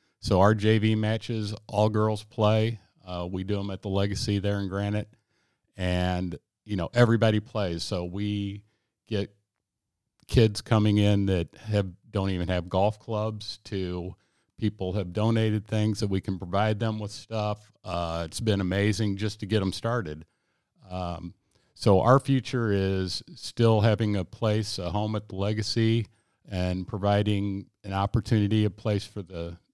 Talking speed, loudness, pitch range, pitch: 155 wpm, -27 LUFS, 95-110 Hz, 105 Hz